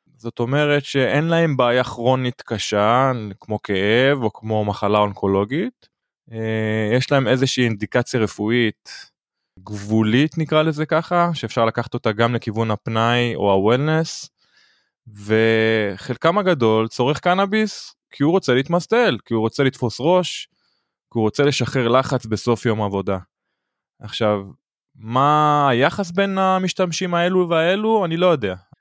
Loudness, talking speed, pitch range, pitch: -19 LUFS, 125 wpm, 110-155 Hz, 125 Hz